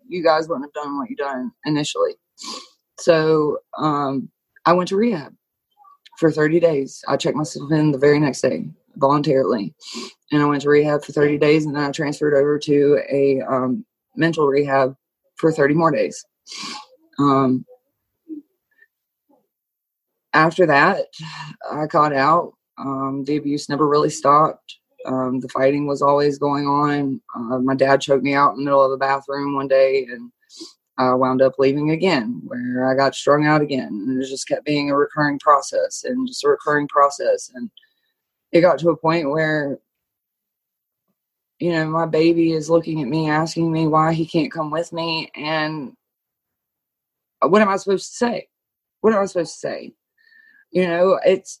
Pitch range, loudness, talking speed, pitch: 140-180 Hz, -19 LUFS, 170 wpm, 155 Hz